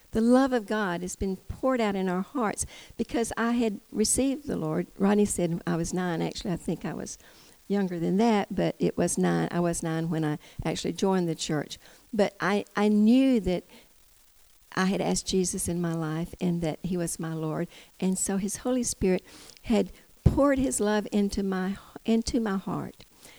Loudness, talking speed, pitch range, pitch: -28 LUFS, 190 wpm, 170-215 Hz, 190 Hz